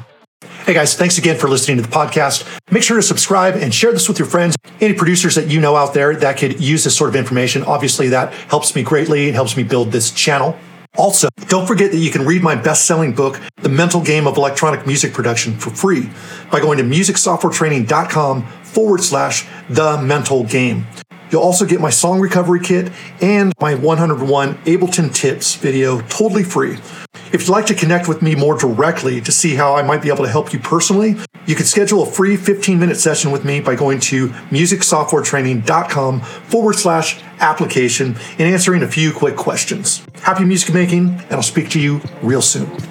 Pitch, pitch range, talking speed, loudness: 155 Hz, 140-180 Hz, 195 wpm, -14 LUFS